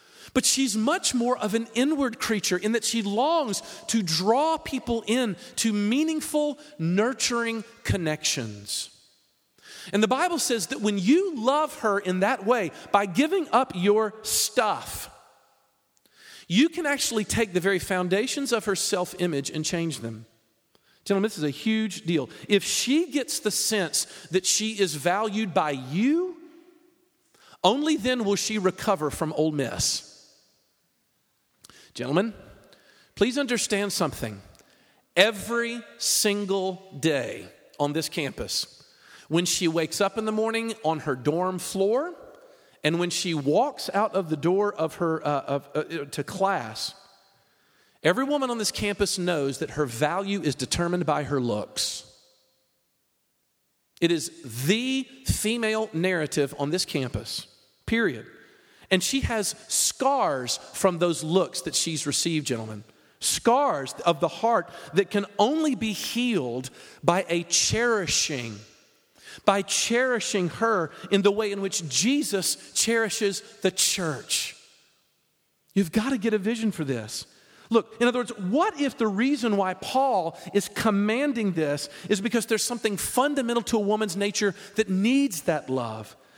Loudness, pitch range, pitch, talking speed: -25 LUFS, 165-235 Hz, 200 Hz, 140 wpm